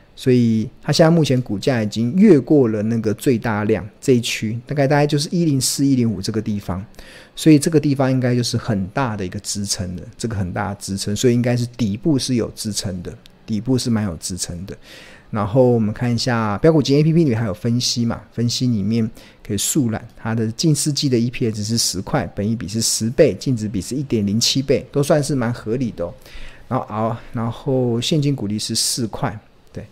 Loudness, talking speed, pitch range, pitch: -19 LUFS, 315 characters per minute, 105-130 Hz, 115 Hz